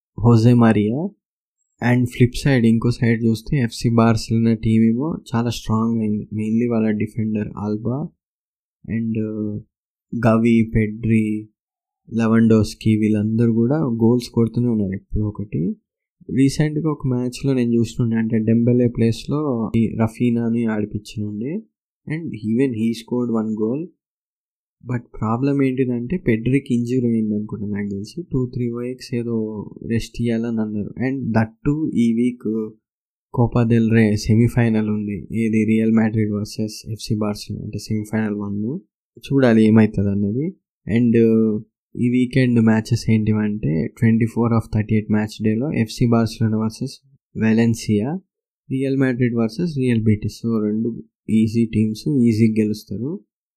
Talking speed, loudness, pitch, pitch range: 125 wpm, -20 LUFS, 115 Hz, 110-120 Hz